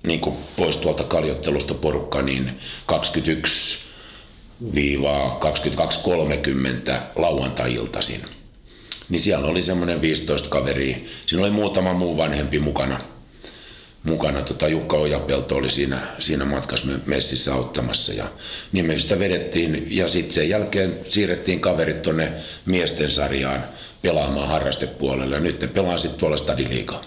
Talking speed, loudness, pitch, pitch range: 120 wpm, -22 LUFS, 70 Hz, 65-85 Hz